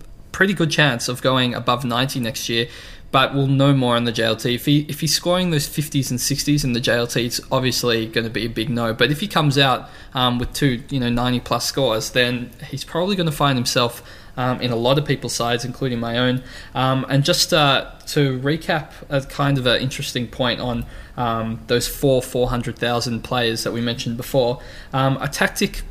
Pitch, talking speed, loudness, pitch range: 125 Hz, 220 wpm, -20 LUFS, 120-140 Hz